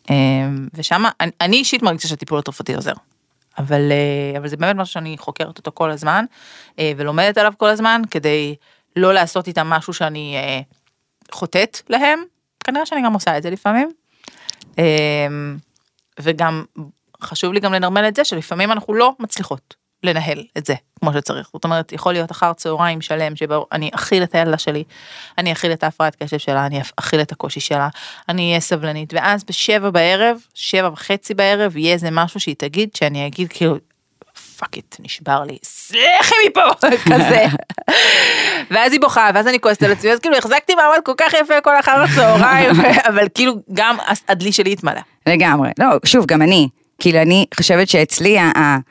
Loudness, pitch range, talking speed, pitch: -15 LUFS, 150-215 Hz, 170 wpm, 170 Hz